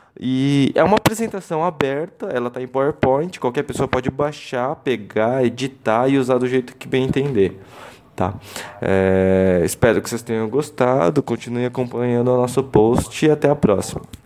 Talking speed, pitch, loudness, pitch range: 160 wpm, 130 Hz, -19 LUFS, 120-140 Hz